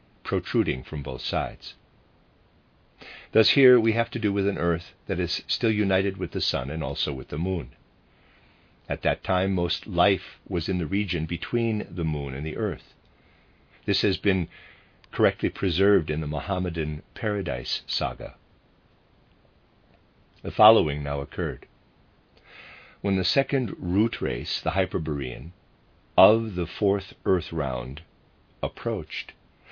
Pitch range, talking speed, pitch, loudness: 80-100 Hz, 135 wpm, 90 Hz, -25 LUFS